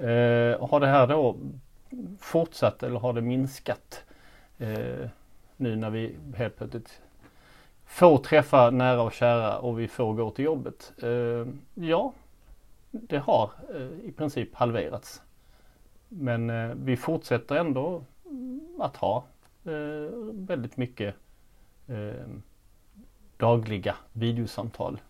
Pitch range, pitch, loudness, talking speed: 115-150 Hz, 125 Hz, -27 LUFS, 115 wpm